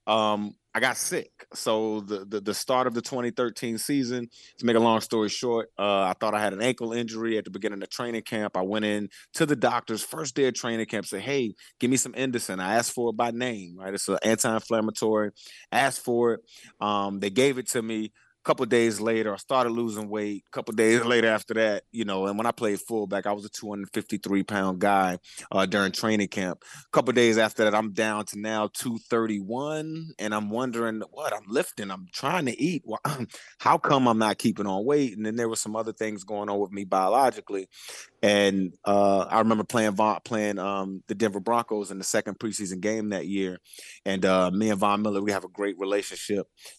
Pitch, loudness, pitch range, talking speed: 110 Hz, -26 LUFS, 100-115 Hz, 220 wpm